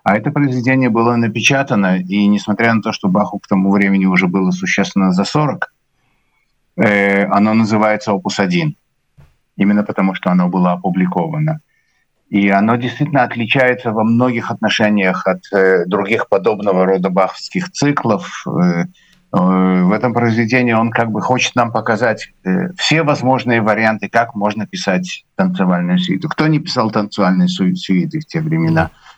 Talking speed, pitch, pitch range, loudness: 140 wpm, 110 Hz, 100-140 Hz, -15 LUFS